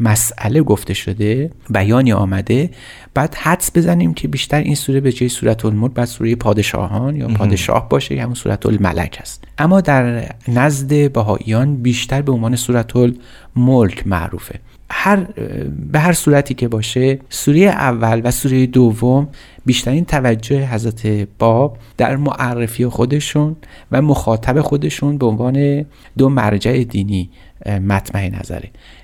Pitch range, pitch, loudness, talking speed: 105-135 Hz, 120 Hz, -15 LUFS, 130 wpm